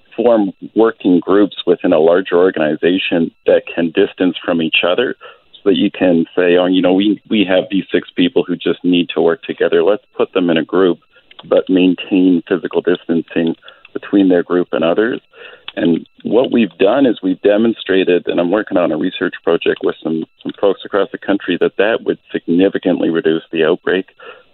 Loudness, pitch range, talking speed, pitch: -15 LUFS, 85-95 Hz, 185 wpm, 90 Hz